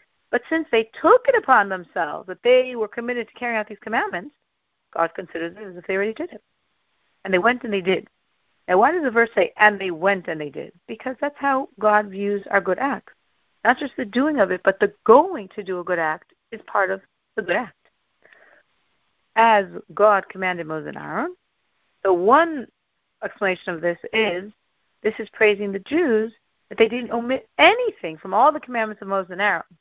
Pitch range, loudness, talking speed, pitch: 190-245 Hz, -21 LUFS, 205 wpm, 210 Hz